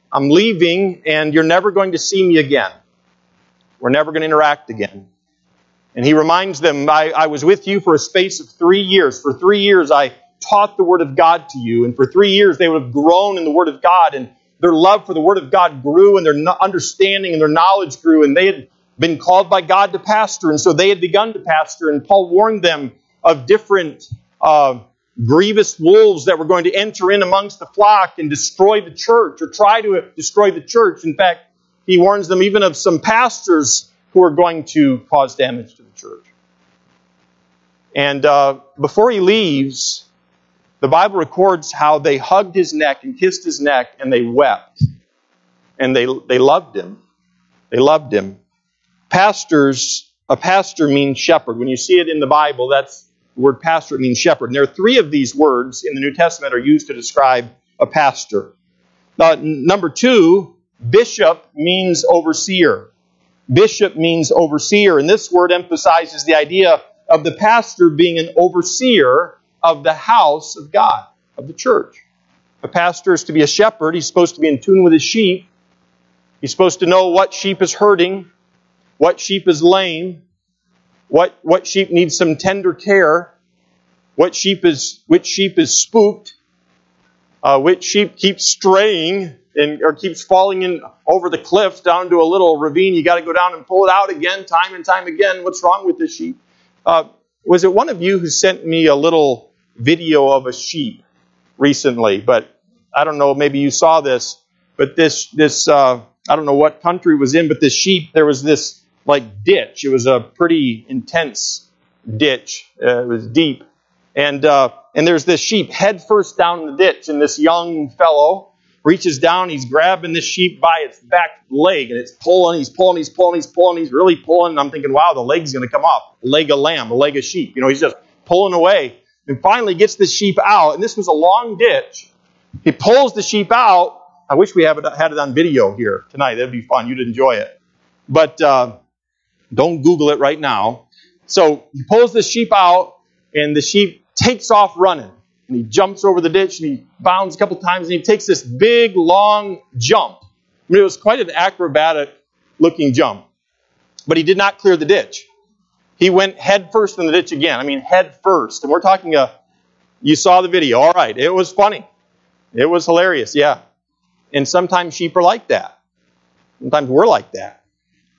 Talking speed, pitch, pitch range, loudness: 195 wpm, 170 Hz, 140-190 Hz, -13 LUFS